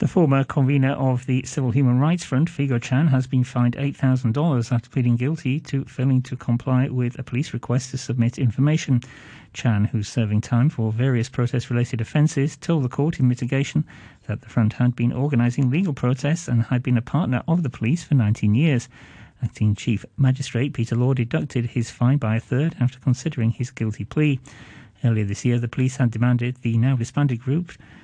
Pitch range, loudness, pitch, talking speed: 120-140 Hz, -22 LUFS, 130 Hz, 190 wpm